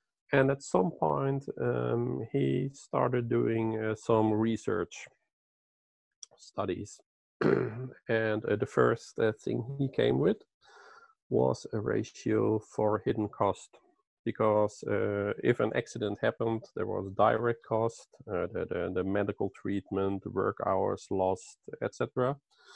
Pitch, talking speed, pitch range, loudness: 110 Hz, 125 wpm, 100-125 Hz, -31 LUFS